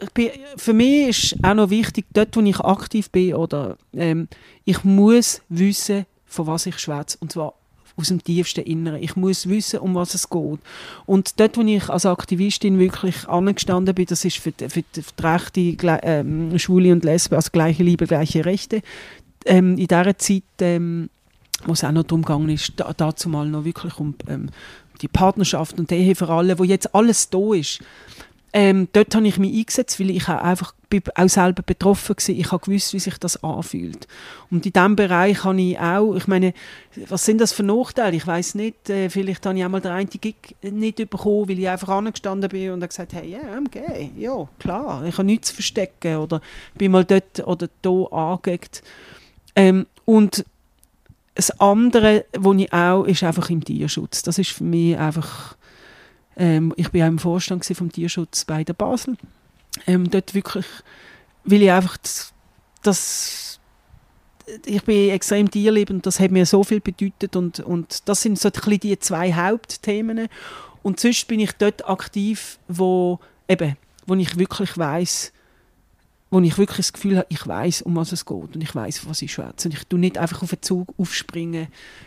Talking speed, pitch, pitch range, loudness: 185 wpm, 185 Hz, 170-200 Hz, -20 LUFS